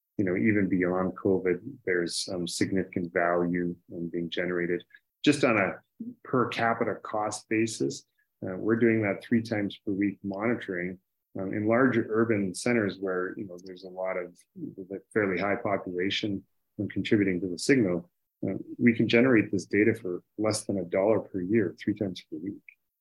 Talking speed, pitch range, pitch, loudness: 170 wpm, 90-110 Hz, 100 Hz, -28 LUFS